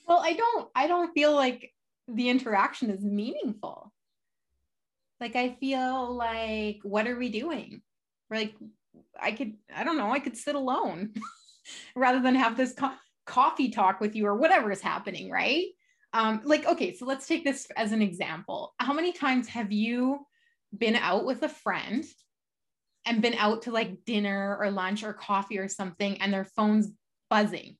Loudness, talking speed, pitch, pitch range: -28 LUFS, 175 wpm, 235 Hz, 210-275 Hz